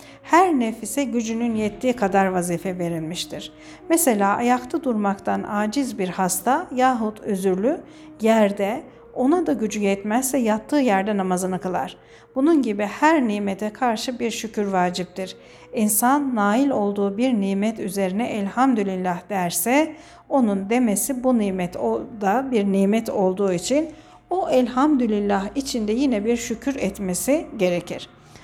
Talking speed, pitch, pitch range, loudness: 120 wpm, 220 Hz, 195-260 Hz, -22 LUFS